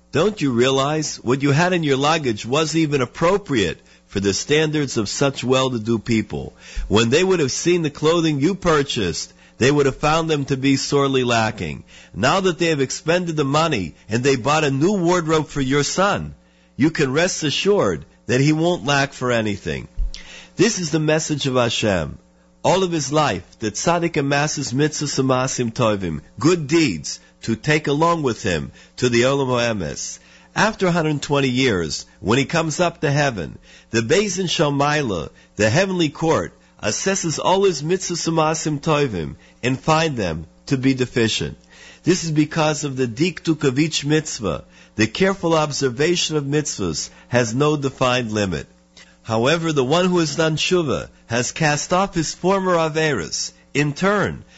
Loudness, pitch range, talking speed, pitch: -19 LUFS, 115-160 Hz, 160 wpm, 145 Hz